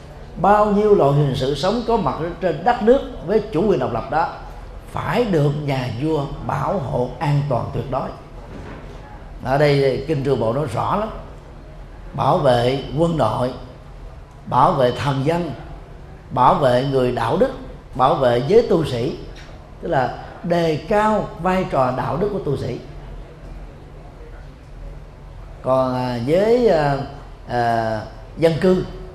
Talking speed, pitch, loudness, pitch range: 145 wpm, 135 Hz, -19 LUFS, 125-170 Hz